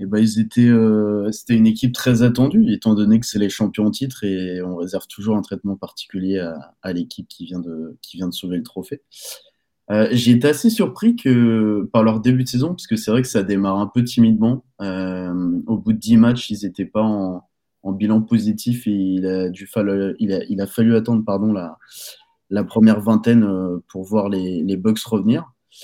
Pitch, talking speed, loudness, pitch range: 110 Hz, 220 wpm, -18 LUFS, 95-115 Hz